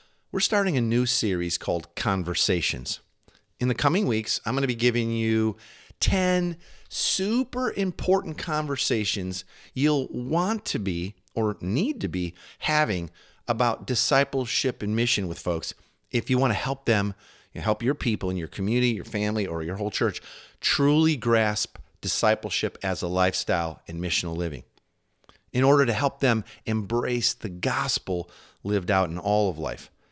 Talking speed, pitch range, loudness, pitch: 155 wpm, 95-130 Hz, -26 LUFS, 110 Hz